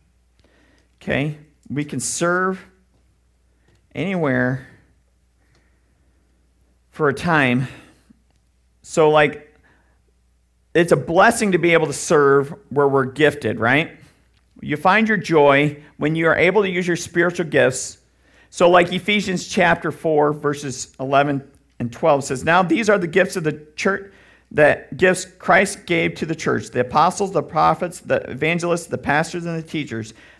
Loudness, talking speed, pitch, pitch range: -18 LUFS, 140 wpm, 150 Hz, 120-175 Hz